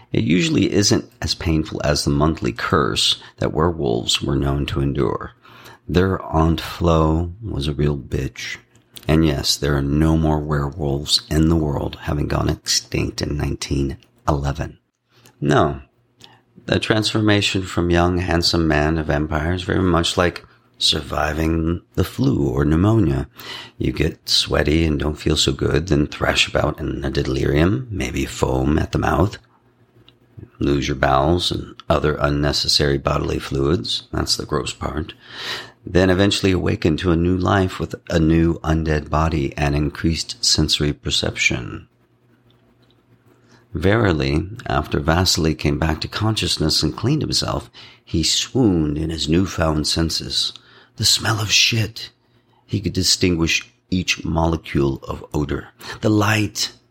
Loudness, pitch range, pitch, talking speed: -19 LUFS, 75-95 Hz, 80 Hz, 140 wpm